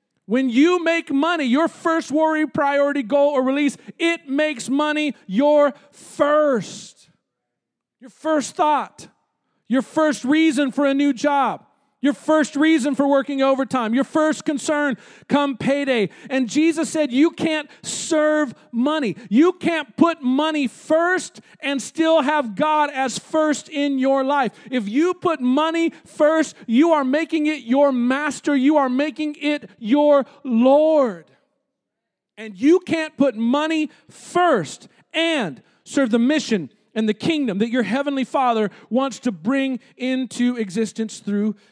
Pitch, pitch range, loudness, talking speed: 285 Hz, 250-305 Hz, -20 LUFS, 140 wpm